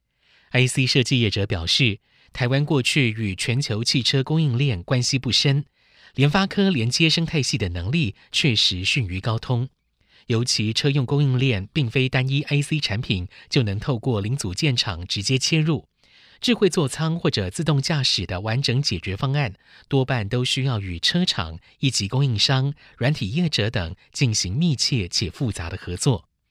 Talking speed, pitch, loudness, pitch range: 255 characters per minute, 130 Hz, -22 LUFS, 105-145 Hz